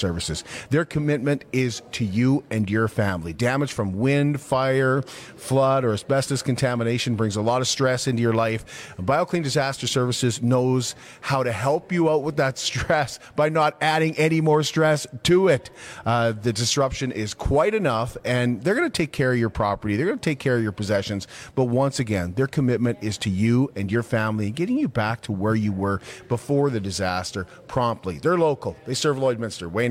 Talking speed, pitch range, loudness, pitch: 195 wpm, 110-140 Hz, -23 LUFS, 125 Hz